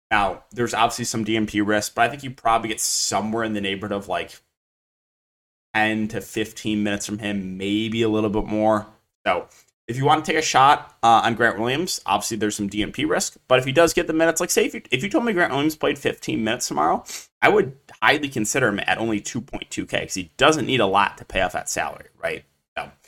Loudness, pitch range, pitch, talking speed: -22 LUFS, 105-120 Hz, 110 Hz, 225 wpm